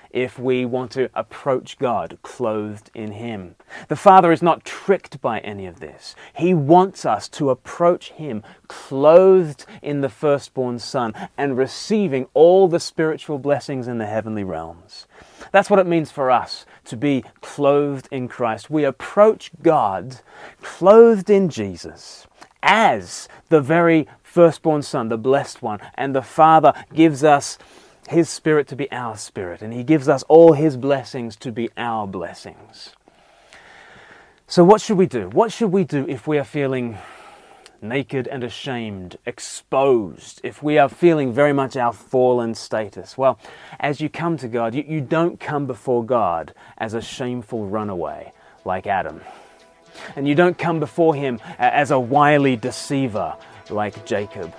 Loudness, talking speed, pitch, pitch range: -18 LUFS, 155 wpm, 140 Hz, 120-160 Hz